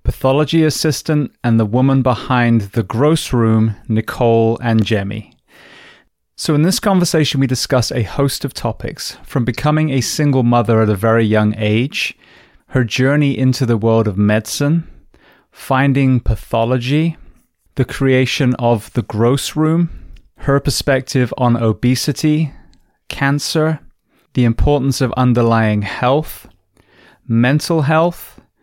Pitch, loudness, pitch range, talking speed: 130 Hz, -15 LUFS, 115-145 Hz, 125 wpm